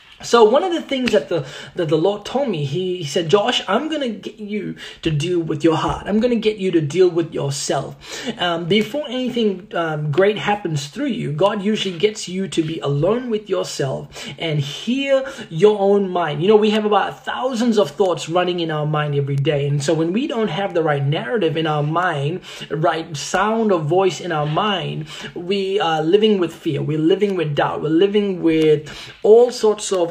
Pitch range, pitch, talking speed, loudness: 160-210 Hz, 185 Hz, 205 wpm, -19 LUFS